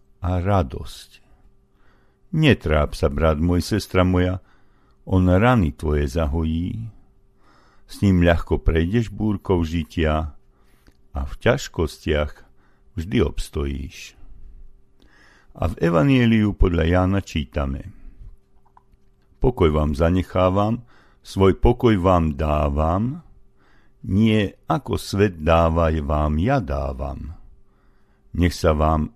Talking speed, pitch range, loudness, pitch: 95 wpm, 75-95 Hz, -21 LUFS, 85 Hz